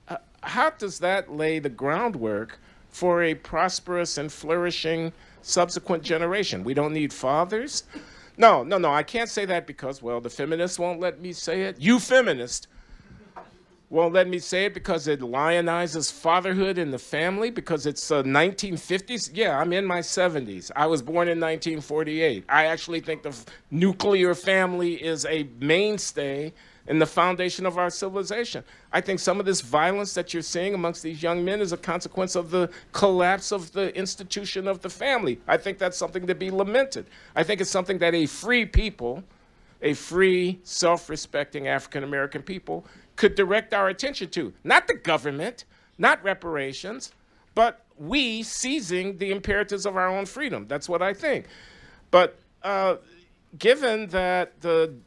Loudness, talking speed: -25 LUFS, 165 wpm